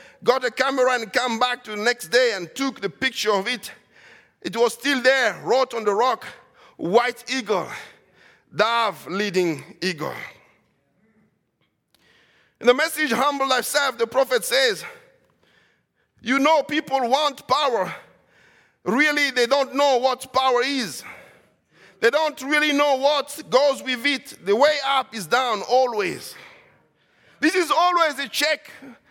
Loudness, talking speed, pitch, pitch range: -21 LUFS, 140 wpm, 260 Hz, 235-290 Hz